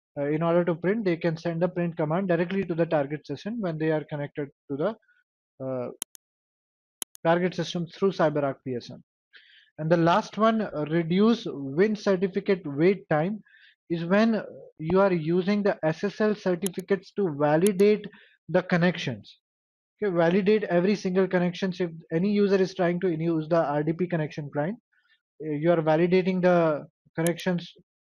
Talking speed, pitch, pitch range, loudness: 150 wpm, 175 Hz, 160-195 Hz, -26 LUFS